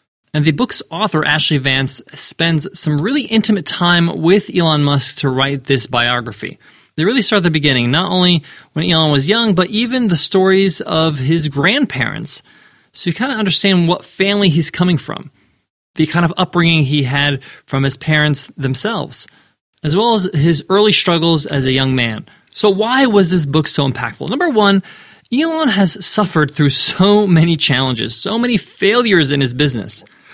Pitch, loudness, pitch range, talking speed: 165 Hz, -14 LUFS, 145-195 Hz, 175 wpm